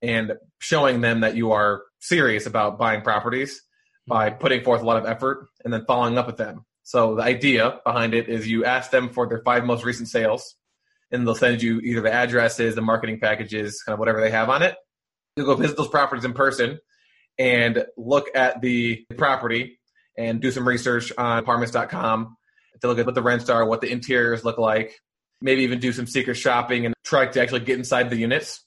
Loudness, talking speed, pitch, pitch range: -22 LUFS, 205 wpm, 120 Hz, 115-125 Hz